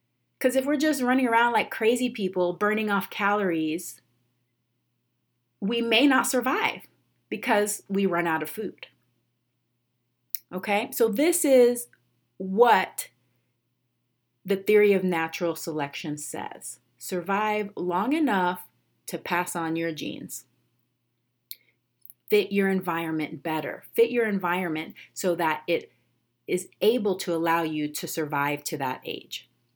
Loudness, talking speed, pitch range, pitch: -25 LUFS, 125 wpm, 125-210 Hz, 175 Hz